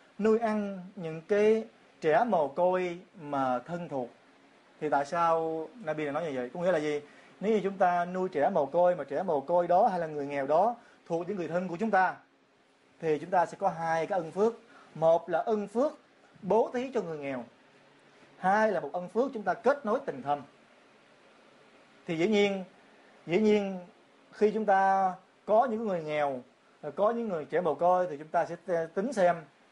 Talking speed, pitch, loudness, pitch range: 200 wpm, 180 Hz, -29 LUFS, 160-205 Hz